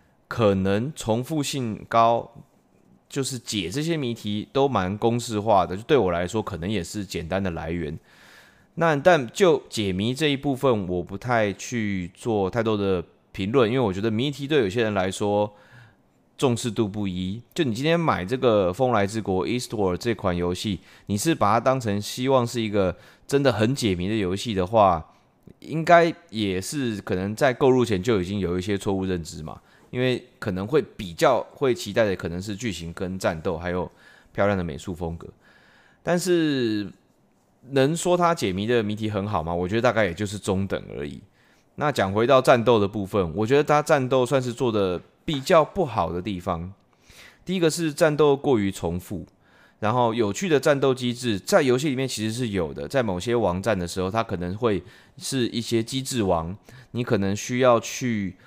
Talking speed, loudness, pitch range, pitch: 275 characters per minute, -24 LUFS, 95-125 Hz, 110 Hz